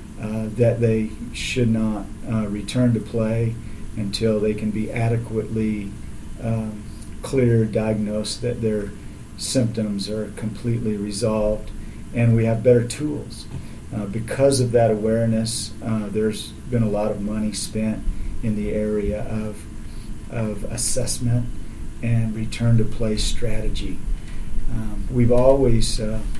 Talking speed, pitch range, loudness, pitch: 125 wpm, 105-115 Hz, -23 LUFS, 110 Hz